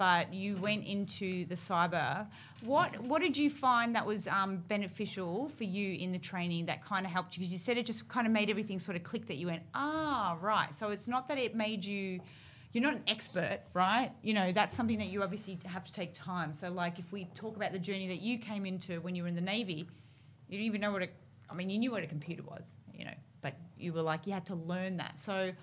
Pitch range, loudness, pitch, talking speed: 175-215 Hz, -35 LUFS, 190 Hz, 255 wpm